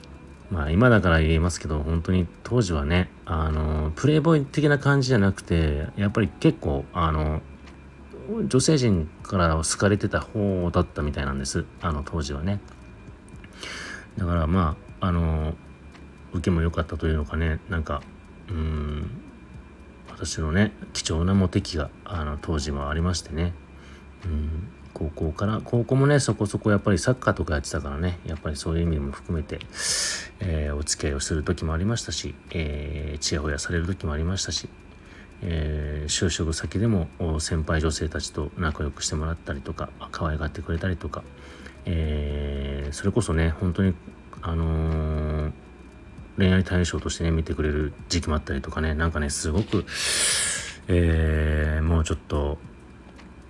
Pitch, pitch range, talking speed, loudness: 80 Hz, 75-95 Hz, 320 characters per minute, -25 LUFS